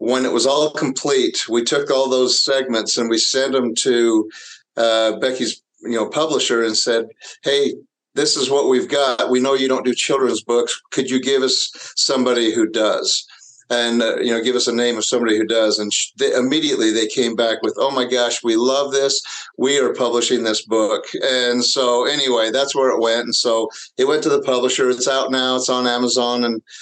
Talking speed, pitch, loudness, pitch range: 210 wpm, 125 Hz, -17 LUFS, 115-135 Hz